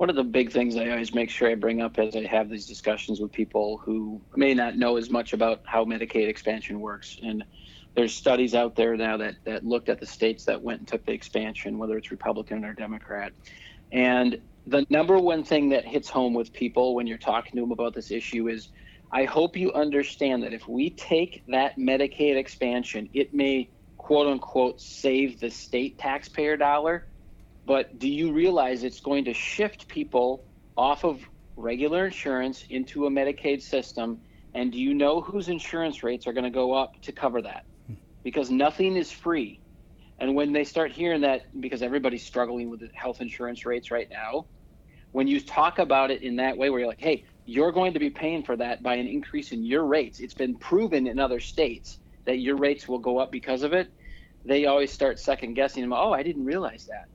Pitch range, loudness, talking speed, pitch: 115-145 Hz, -26 LUFS, 205 wpm, 130 Hz